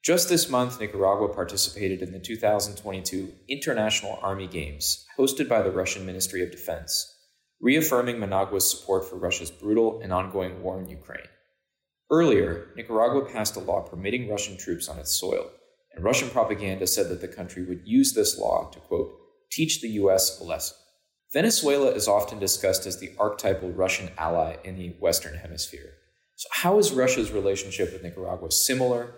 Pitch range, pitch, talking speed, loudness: 95-125 Hz, 100 Hz, 160 wpm, -25 LUFS